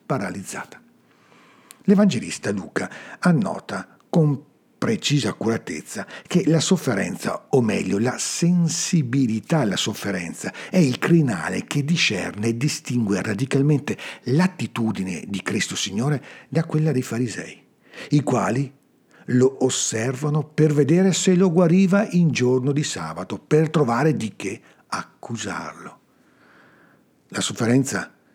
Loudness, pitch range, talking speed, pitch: -22 LUFS, 125-170 Hz, 110 wpm, 145 Hz